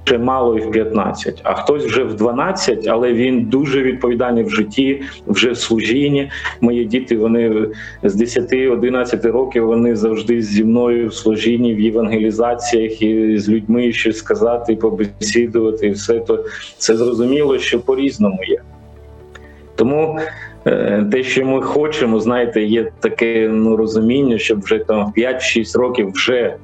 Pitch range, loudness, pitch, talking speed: 110-125 Hz, -16 LUFS, 115 Hz, 145 wpm